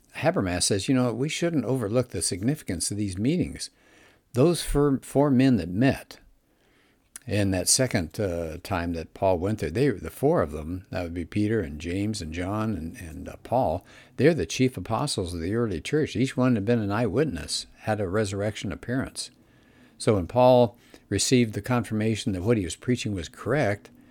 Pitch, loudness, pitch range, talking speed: 110 Hz, -26 LUFS, 95-125 Hz, 185 wpm